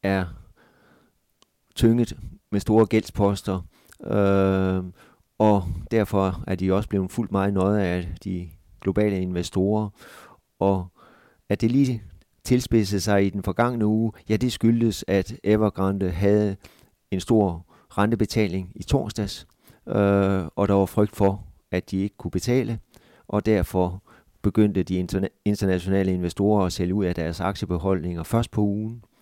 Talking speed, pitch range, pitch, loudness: 140 wpm, 95-105 Hz, 100 Hz, -24 LUFS